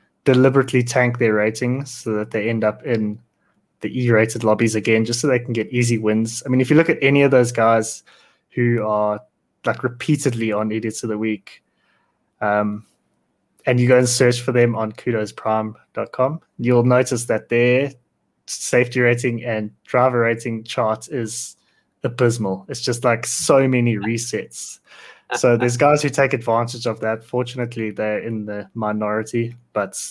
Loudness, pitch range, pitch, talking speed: -19 LUFS, 110-125 Hz, 120 Hz, 165 wpm